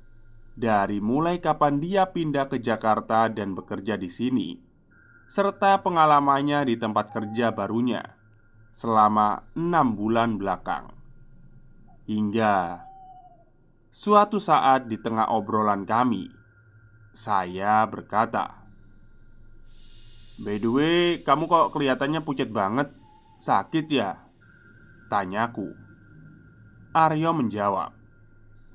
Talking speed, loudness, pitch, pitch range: 90 wpm, -24 LUFS, 115 Hz, 110-145 Hz